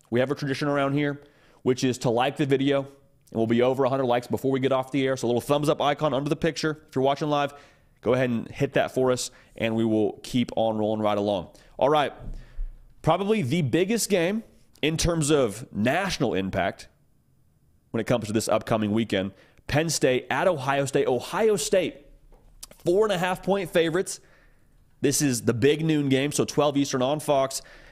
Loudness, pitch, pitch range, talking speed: -25 LUFS, 140 Hz, 120-155 Hz, 200 wpm